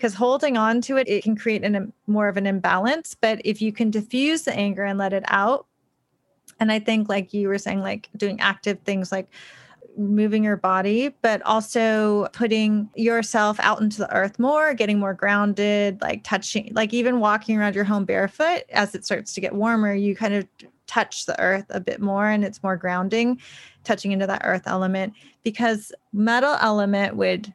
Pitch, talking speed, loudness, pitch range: 210 Hz, 195 wpm, -22 LUFS, 200-225 Hz